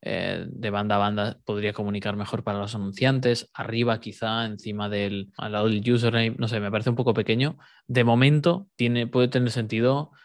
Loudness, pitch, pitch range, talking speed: -25 LUFS, 115 Hz, 105-120 Hz, 185 wpm